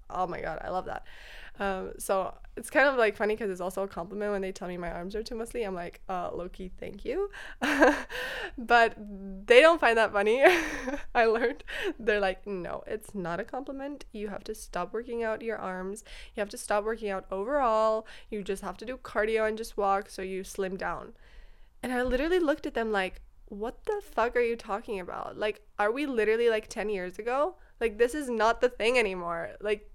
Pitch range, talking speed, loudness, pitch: 195-240 Hz, 210 wpm, -29 LUFS, 220 Hz